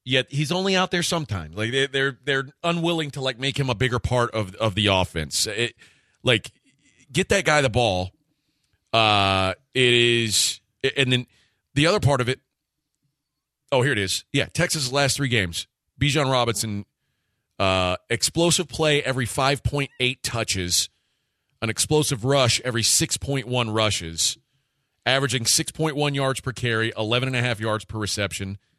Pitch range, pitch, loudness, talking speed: 110-140 Hz, 125 Hz, -22 LUFS, 165 wpm